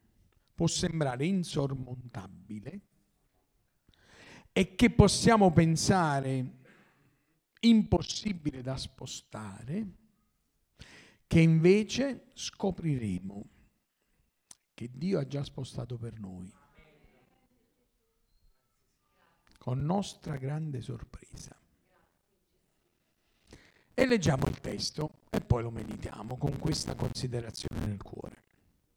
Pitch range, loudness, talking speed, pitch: 115-180 Hz, -30 LUFS, 75 wpm, 140 Hz